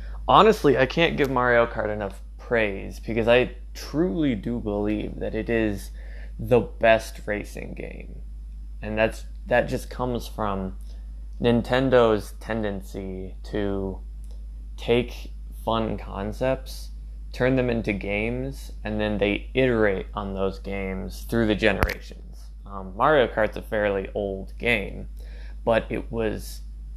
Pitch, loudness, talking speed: 100 Hz, -24 LUFS, 125 wpm